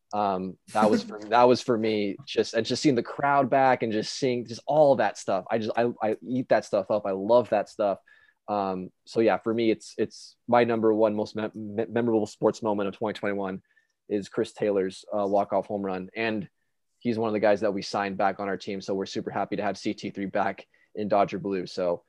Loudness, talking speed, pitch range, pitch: -26 LUFS, 235 wpm, 100-115 Hz, 105 Hz